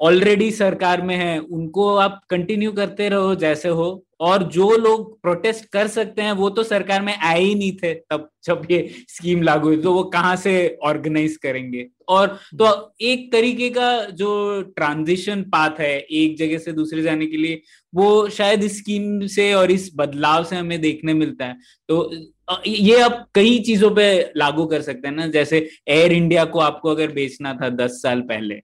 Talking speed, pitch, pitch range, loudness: 185 wpm, 180 Hz, 155-205 Hz, -19 LUFS